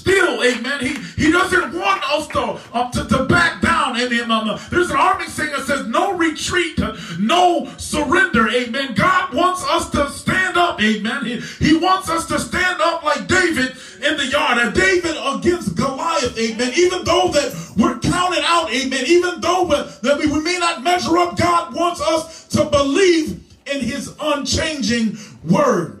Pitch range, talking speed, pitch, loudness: 250-345 Hz, 175 wpm, 300 Hz, -17 LUFS